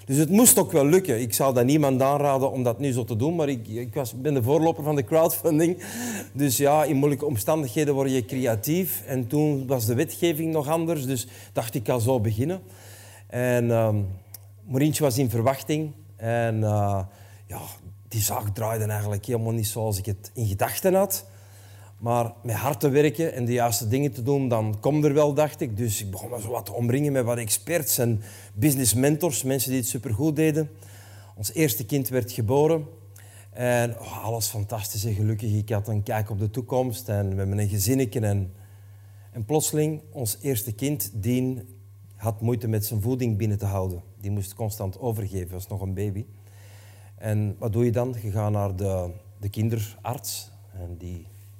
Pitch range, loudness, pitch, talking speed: 100-135 Hz, -25 LUFS, 115 Hz, 195 wpm